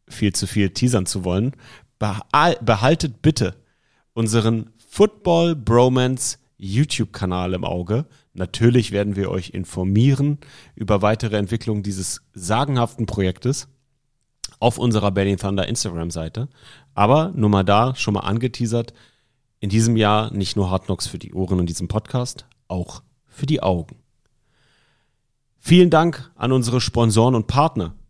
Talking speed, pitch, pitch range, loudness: 135 wpm, 115 Hz, 100-130 Hz, -20 LUFS